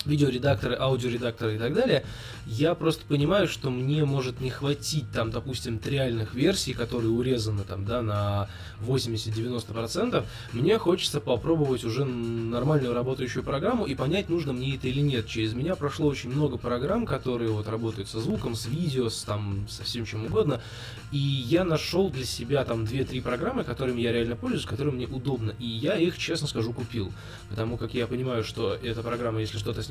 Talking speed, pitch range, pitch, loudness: 175 wpm, 115-140 Hz, 125 Hz, -28 LUFS